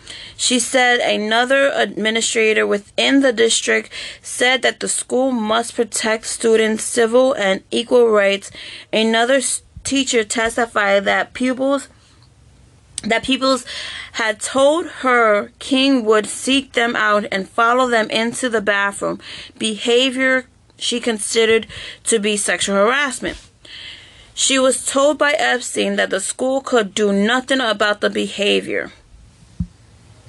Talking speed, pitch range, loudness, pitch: 120 wpm, 210-255 Hz, -17 LUFS, 230 Hz